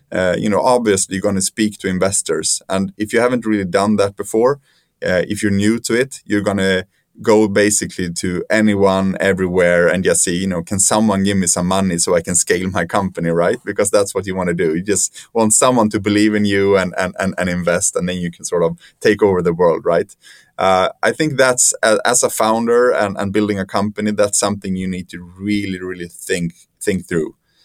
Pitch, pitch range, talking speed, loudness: 100 Hz, 95-105 Hz, 220 wpm, -16 LUFS